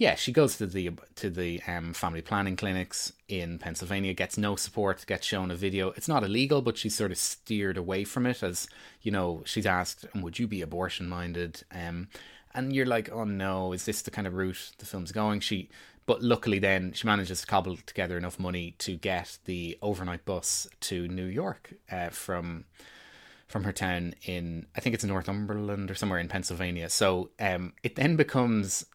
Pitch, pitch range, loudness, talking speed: 95 Hz, 90-105 Hz, -31 LUFS, 195 wpm